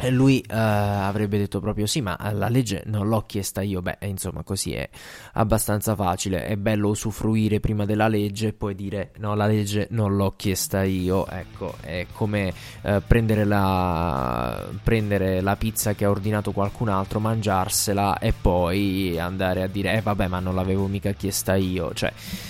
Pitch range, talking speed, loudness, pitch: 95-105 Hz, 170 wpm, -24 LUFS, 100 Hz